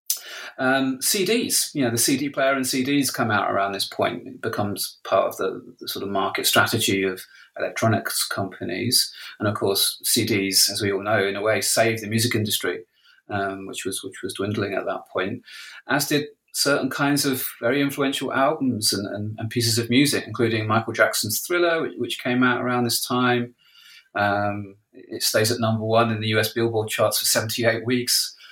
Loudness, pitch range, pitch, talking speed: -22 LUFS, 110-130 Hz, 115 Hz, 190 wpm